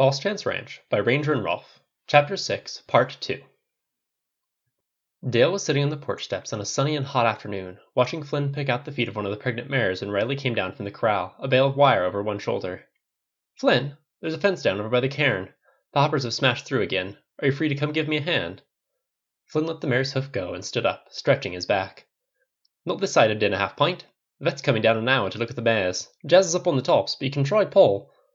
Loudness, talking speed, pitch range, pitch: -24 LUFS, 245 wpm, 125-160 Hz, 140 Hz